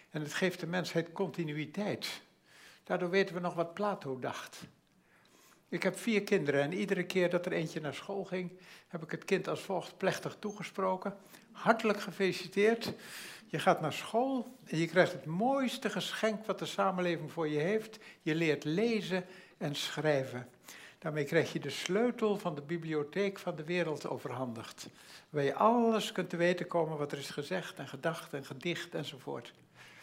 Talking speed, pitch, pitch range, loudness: 170 wpm, 180 Hz, 155-200 Hz, -34 LUFS